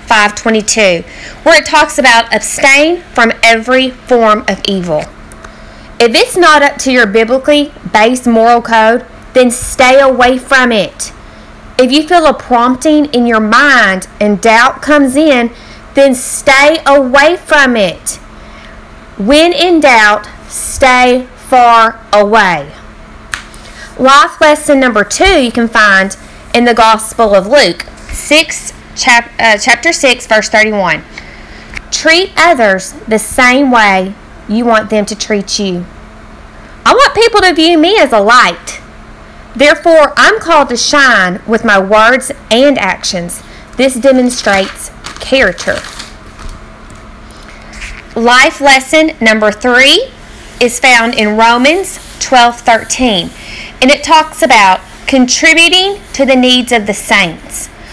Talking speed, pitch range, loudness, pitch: 125 wpm, 220-290 Hz, -7 LUFS, 250 Hz